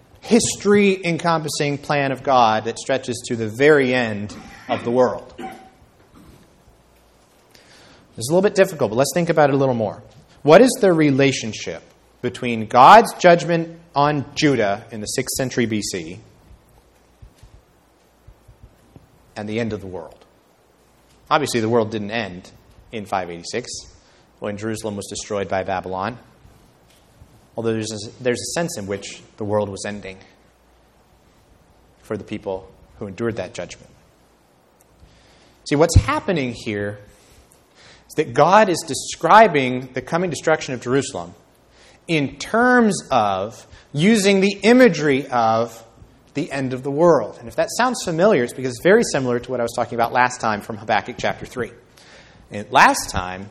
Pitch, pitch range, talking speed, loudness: 125 Hz, 105-150 Hz, 145 wpm, -19 LUFS